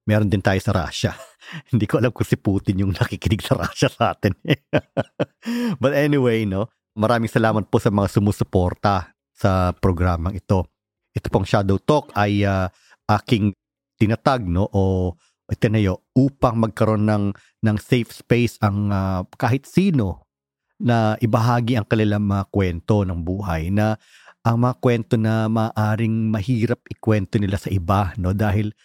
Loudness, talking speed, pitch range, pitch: -21 LUFS, 150 wpm, 100-120 Hz, 105 Hz